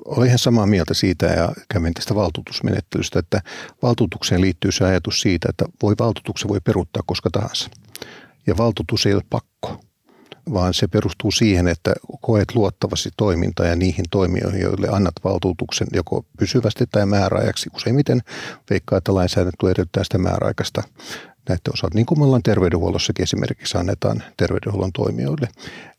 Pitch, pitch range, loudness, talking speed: 100 Hz, 90-110 Hz, -20 LUFS, 145 wpm